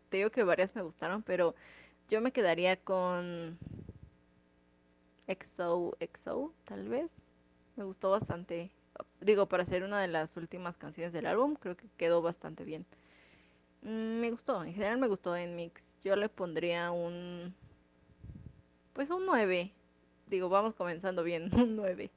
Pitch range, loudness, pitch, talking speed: 150-195 Hz, -35 LUFS, 175 Hz, 145 wpm